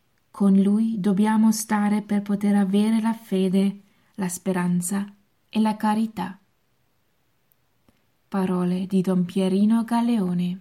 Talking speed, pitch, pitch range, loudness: 100 wpm, 200 Hz, 190-215 Hz, -23 LUFS